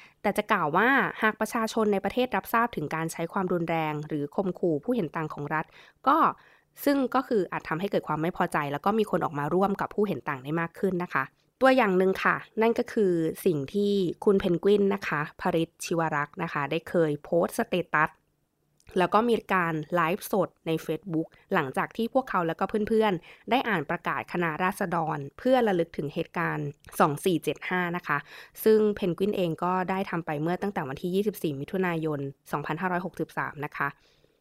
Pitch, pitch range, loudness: 180 Hz, 160-200 Hz, -27 LUFS